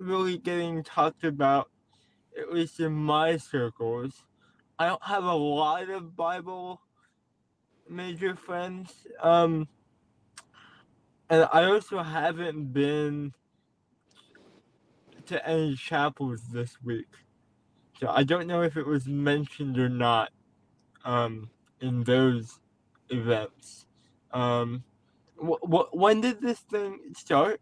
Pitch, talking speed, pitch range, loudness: 150 Hz, 110 wpm, 120-170 Hz, -28 LUFS